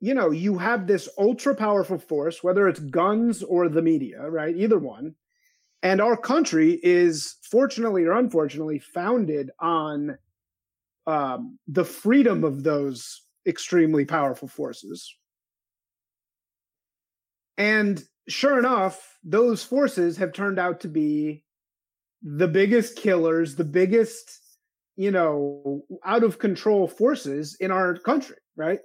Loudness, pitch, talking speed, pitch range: -23 LUFS, 180 Hz, 125 wpm, 150-230 Hz